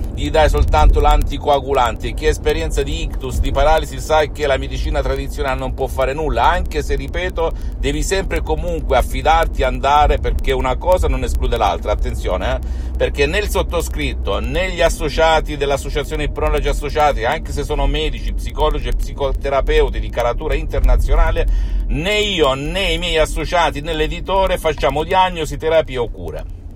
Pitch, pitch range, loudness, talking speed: 150 Hz, 125-160 Hz, -18 LUFS, 155 wpm